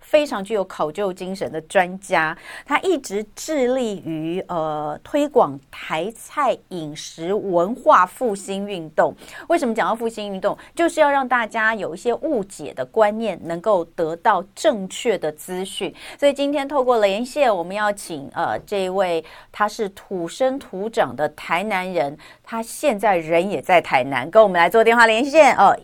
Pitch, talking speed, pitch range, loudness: 205 Hz, 245 characters per minute, 170-240 Hz, -20 LUFS